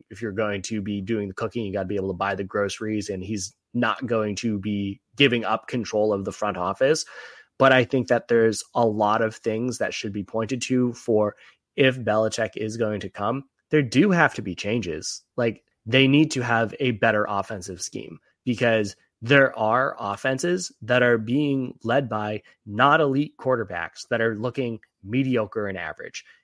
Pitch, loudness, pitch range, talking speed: 115 Hz, -24 LUFS, 105-125 Hz, 190 wpm